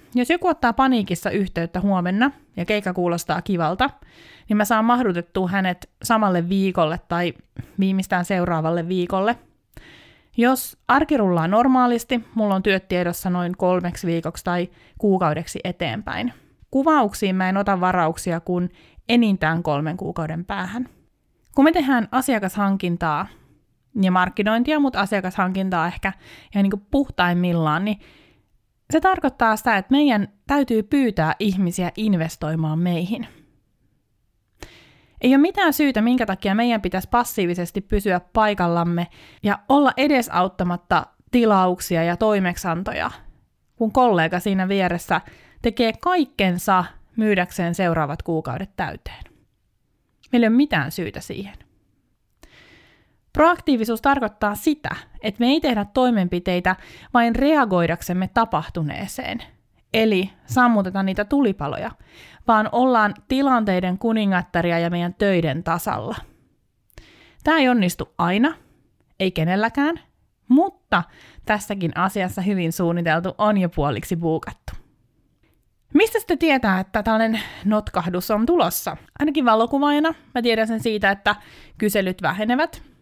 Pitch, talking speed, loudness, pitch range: 195 Hz, 110 wpm, -21 LUFS, 175-235 Hz